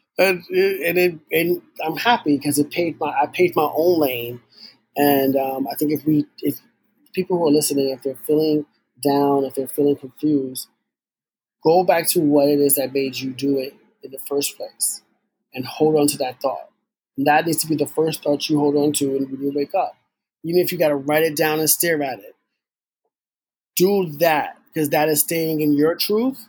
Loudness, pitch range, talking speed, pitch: -20 LUFS, 140-165 Hz, 210 wpm, 150 Hz